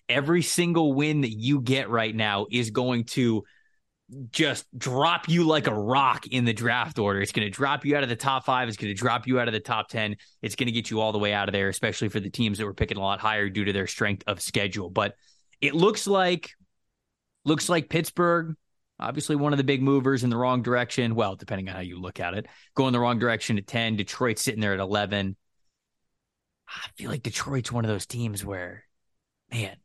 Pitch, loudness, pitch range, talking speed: 120 Hz, -26 LUFS, 105-135 Hz, 230 wpm